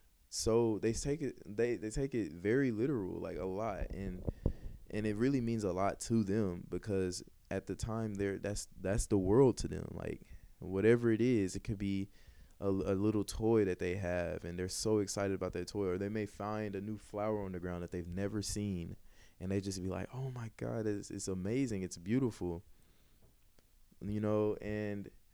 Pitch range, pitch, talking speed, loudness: 95-110 Hz, 100 Hz, 200 wpm, -36 LUFS